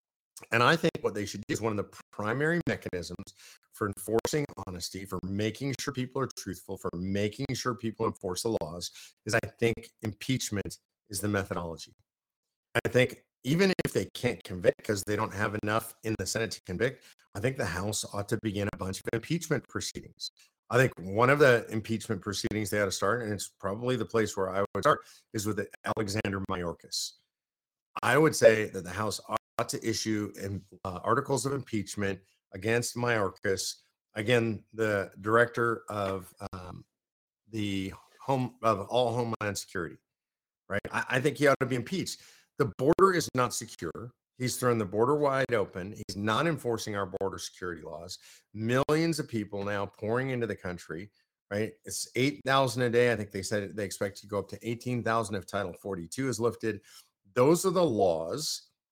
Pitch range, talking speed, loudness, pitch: 100-120 Hz, 180 wpm, -30 LUFS, 110 Hz